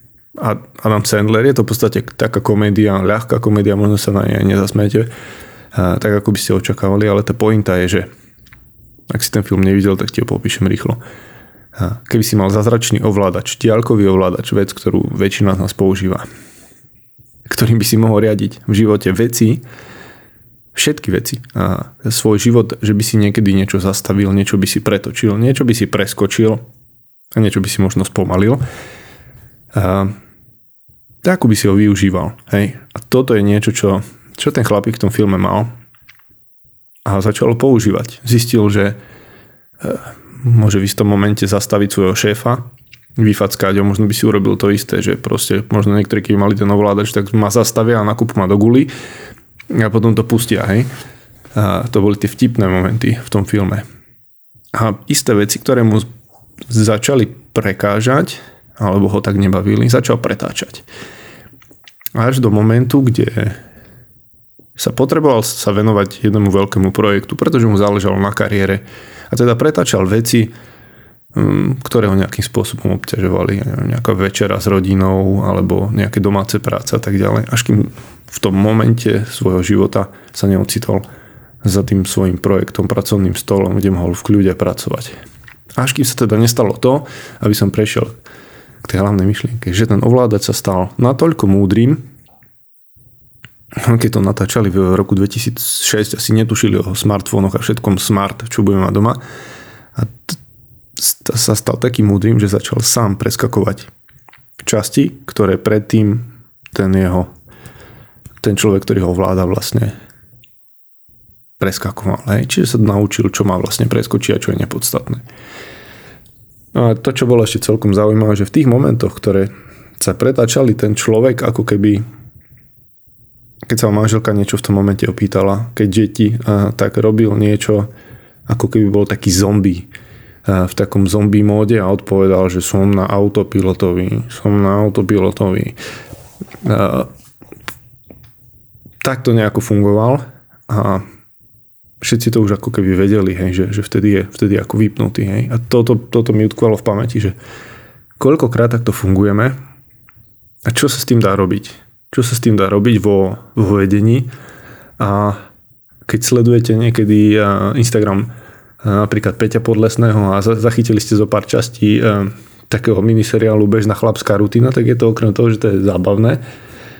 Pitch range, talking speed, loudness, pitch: 100-115 Hz, 150 wpm, -14 LUFS, 105 Hz